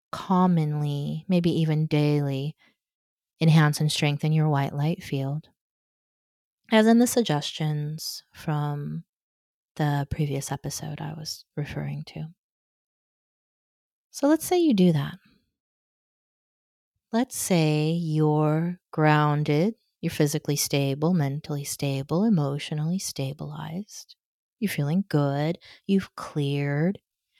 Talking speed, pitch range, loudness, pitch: 100 wpm, 145-175 Hz, -25 LUFS, 155 Hz